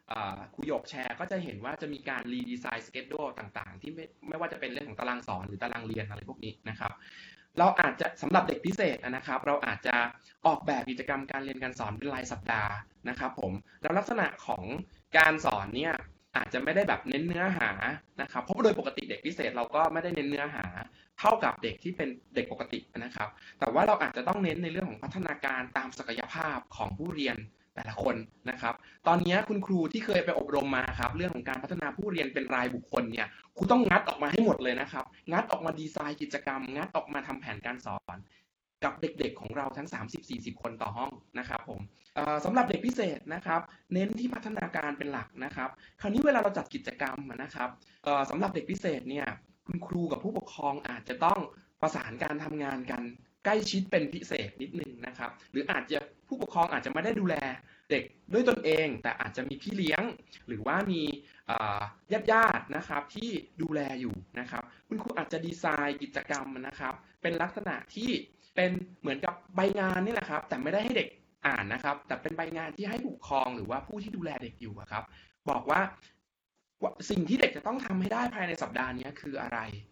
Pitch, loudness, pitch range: 145 Hz, -32 LUFS, 125-180 Hz